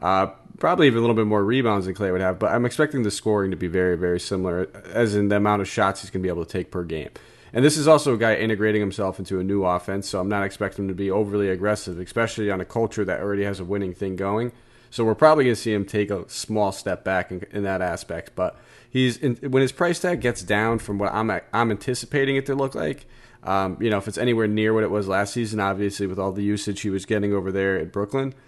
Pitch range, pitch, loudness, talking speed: 95-115 Hz, 105 Hz, -23 LUFS, 270 wpm